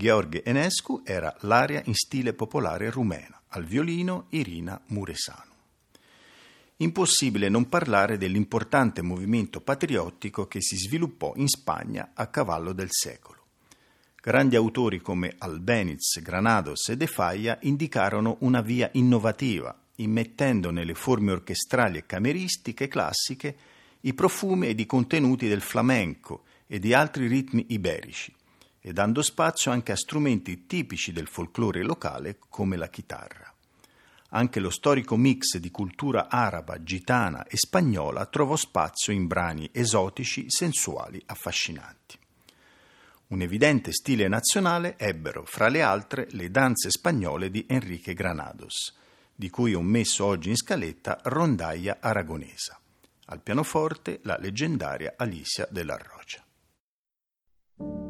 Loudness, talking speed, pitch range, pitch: -26 LUFS, 120 wpm, 95-130 Hz, 115 Hz